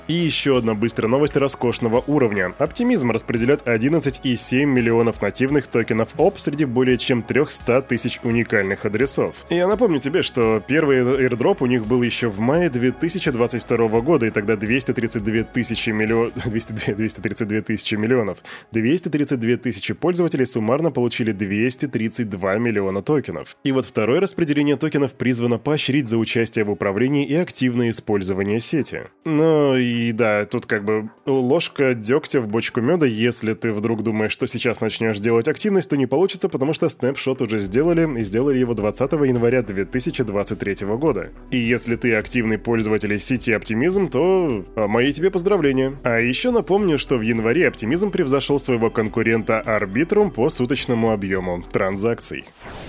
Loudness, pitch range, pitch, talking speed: -20 LUFS, 110-140 Hz, 120 Hz, 145 wpm